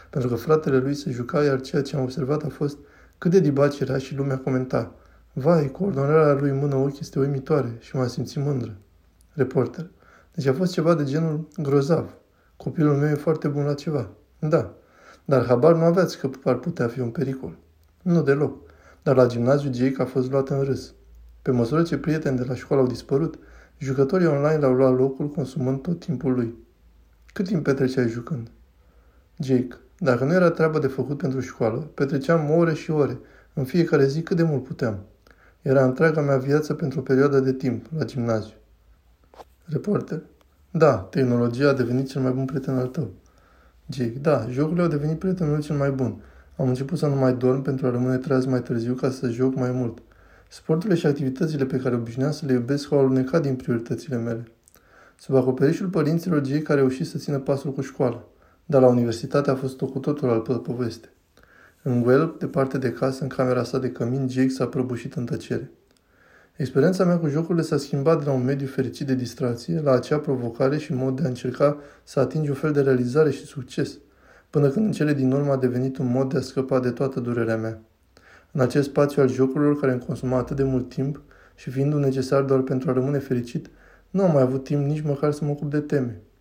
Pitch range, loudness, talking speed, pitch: 125-150 Hz, -23 LUFS, 200 wpm, 135 Hz